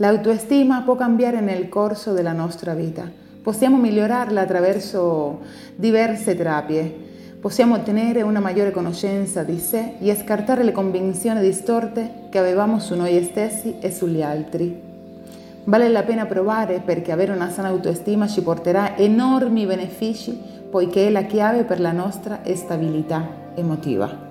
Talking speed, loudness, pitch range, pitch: 145 wpm, -20 LUFS, 175-220 Hz, 200 Hz